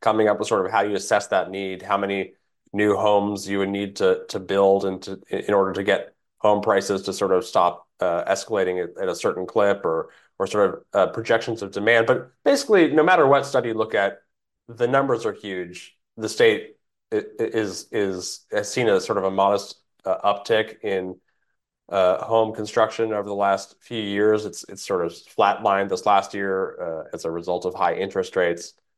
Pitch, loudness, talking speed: 105 Hz, -22 LUFS, 205 wpm